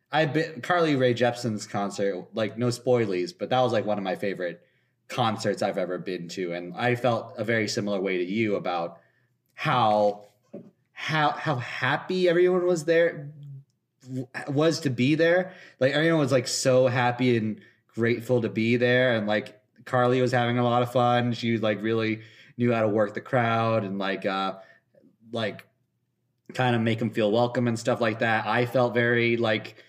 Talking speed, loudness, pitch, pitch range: 180 wpm, -25 LUFS, 120 Hz, 110-130 Hz